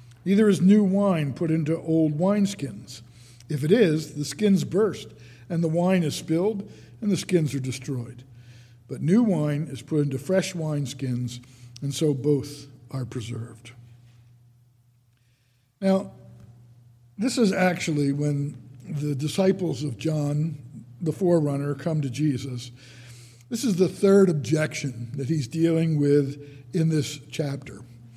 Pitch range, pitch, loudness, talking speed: 120-165 Hz, 145 Hz, -25 LUFS, 135 wpm